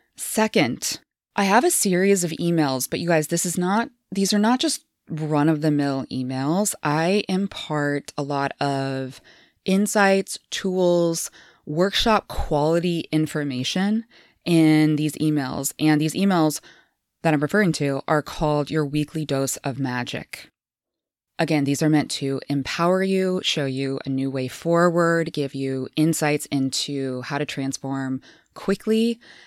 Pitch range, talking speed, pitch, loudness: 140-185 Hz, 145 wpm, 155 Hz, -22 LUFS